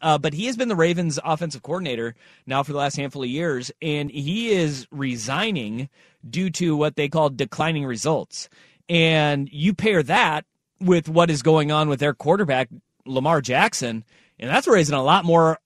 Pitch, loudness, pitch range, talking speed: 155 Hz, -21 LUFS, 140-175 Hz, 180 wpm